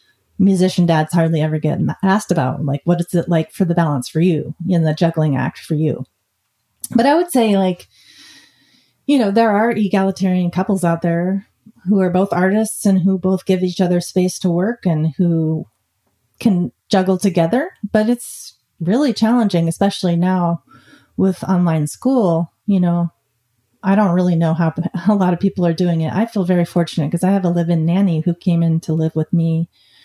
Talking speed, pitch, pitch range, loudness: 195 wpm, 175 Hz, 160-195 Hz, -17 LUFS